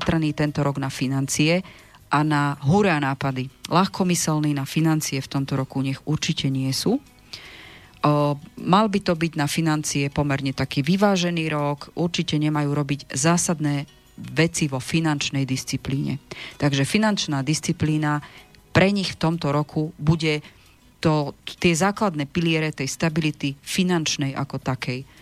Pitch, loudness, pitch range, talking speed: 150 Hz, -23 LUFS, 140-165 Hz, 130 wpm